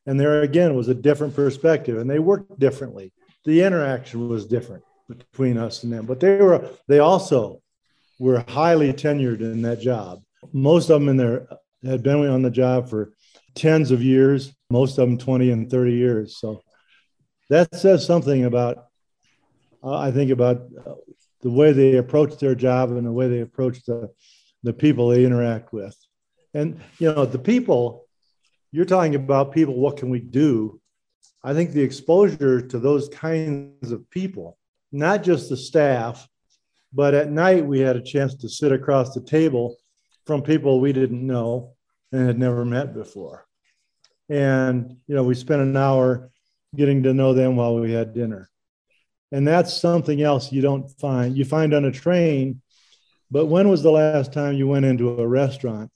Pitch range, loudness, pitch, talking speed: 125-150 Hz, -20 LUFS, 135 Hz, 175 wpm